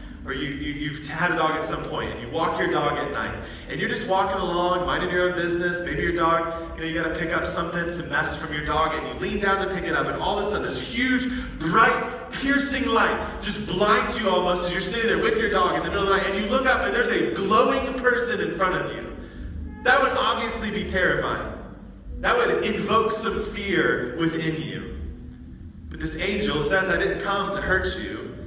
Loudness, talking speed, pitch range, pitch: -24 LUFS, 235 wpm, 165-215 Hz, 190 Hz